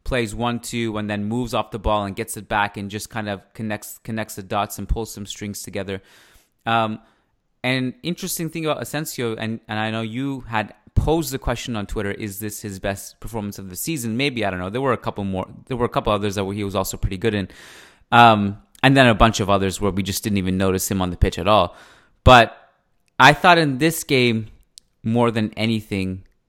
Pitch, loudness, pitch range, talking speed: 110 Hz, -21 LUFS, 100-120 Hz, 225 wpm